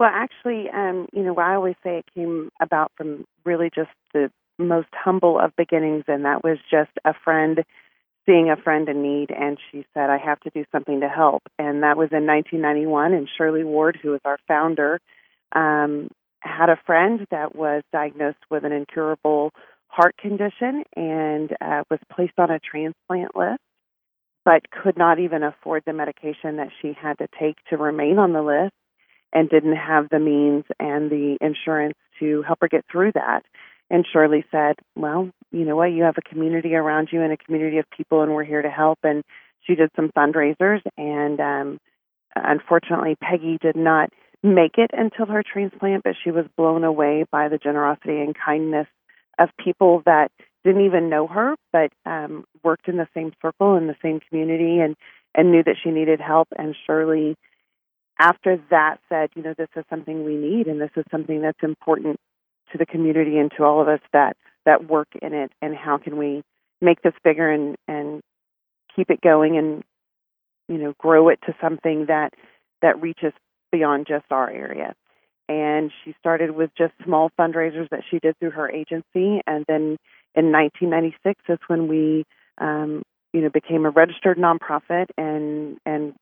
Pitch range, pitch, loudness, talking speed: 150-165 Hz, 155 Hz, -21 LUFS, 185 wpm